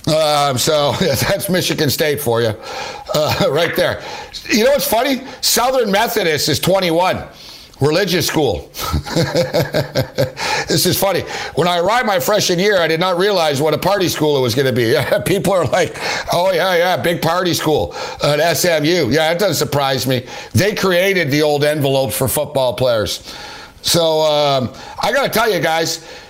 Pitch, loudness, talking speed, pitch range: 155 Hz, -15 LUFS, 175 wpm, 145-180 Hz